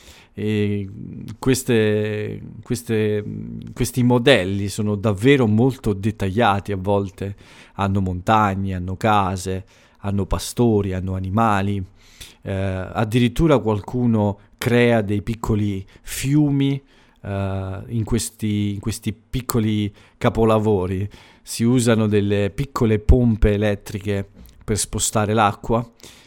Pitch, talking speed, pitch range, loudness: 105 Hz, 95 wpm, 100-115 Hz, -20 LUFS